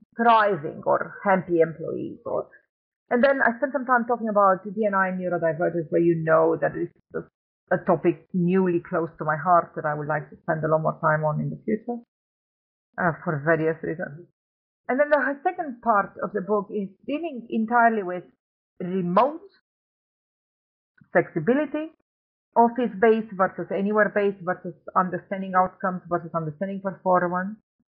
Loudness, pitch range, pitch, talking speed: -24 LUFS, 170-225 Hz, 190 Hz, 150 wpm